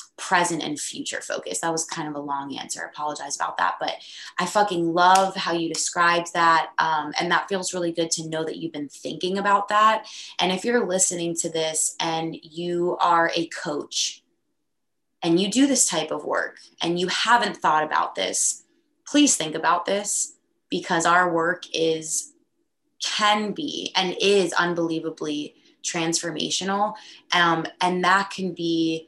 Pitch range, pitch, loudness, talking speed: 165-205 Hz, 175 Hz, -23 LUFS, 165 wpm